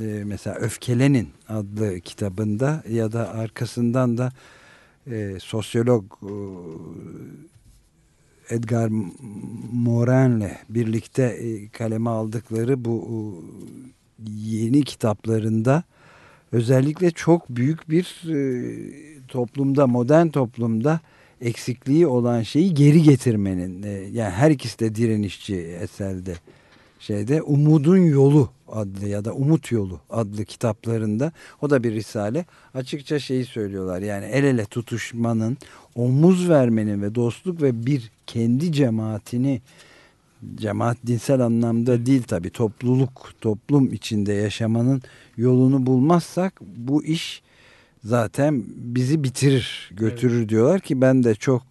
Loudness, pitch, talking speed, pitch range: -22 LUFS, 120 Hz, 110 wpm, 110-135 Hz